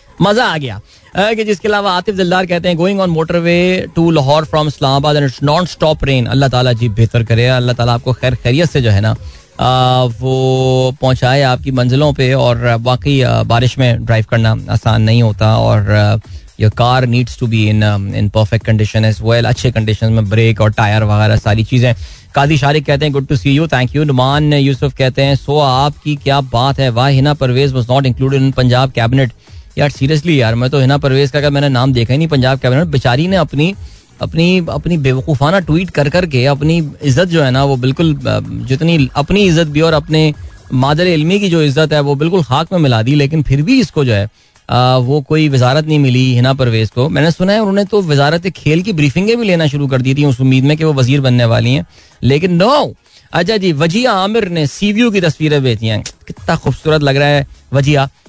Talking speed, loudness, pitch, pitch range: 210 wpm, -12 LUFS, 135 Hz, 120-155 Hz